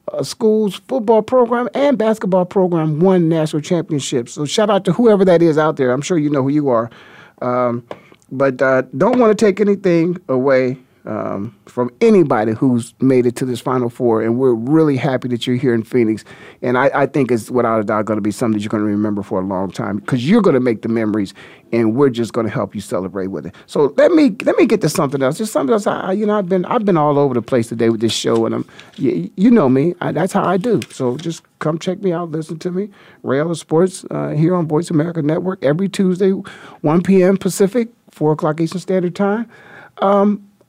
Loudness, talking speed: -16 LUFS, 235 wpm